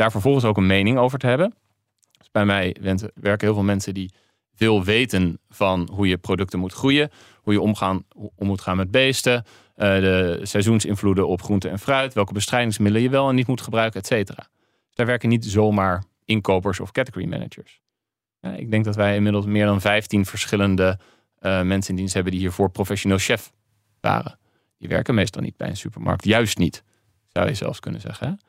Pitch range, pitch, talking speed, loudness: 95-110 Hz, 105 Hz, 195 wpm, -21 LUFS